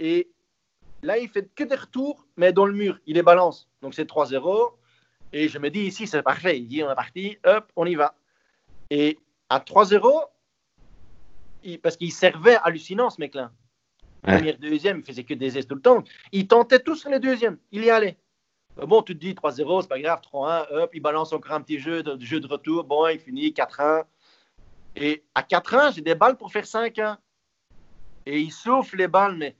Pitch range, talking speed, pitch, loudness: 150-215 Hz, 215 wpm, 170 Hz, -22 LUFS